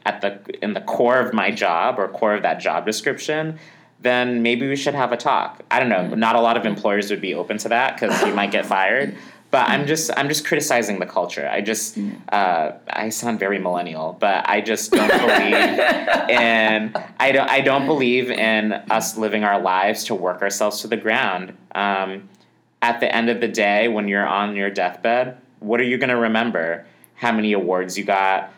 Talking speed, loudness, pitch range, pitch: 210 wpm, -19 LUFS, 100-125 Hz, 110 Hz